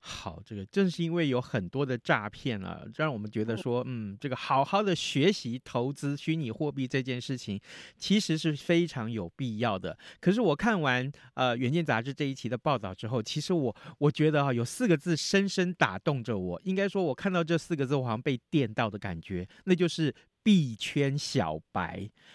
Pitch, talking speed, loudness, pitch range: 135 Hz, 295 characters per minute, -30 LUFS, 115-165 Hz